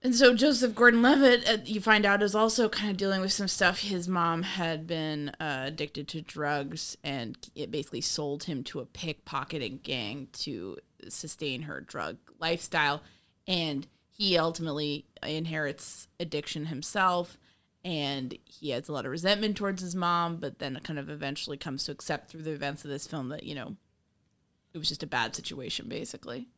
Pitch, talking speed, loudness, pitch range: 160 Hz, 180 wpm, -29 LUFS, 145-195 Hz